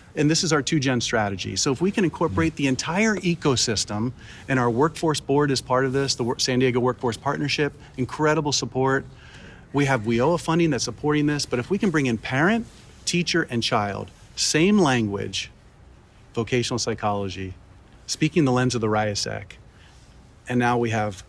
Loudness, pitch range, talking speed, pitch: -23 LUFS, 115-150 Hz, 170 wpm, 130 Hz